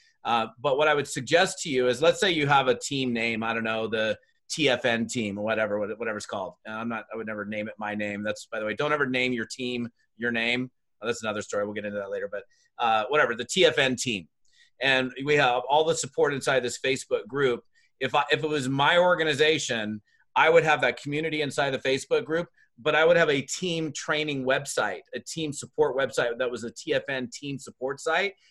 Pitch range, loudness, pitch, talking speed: 115-160 Hz, -26 LUFS, 140 Hz, 220 wpm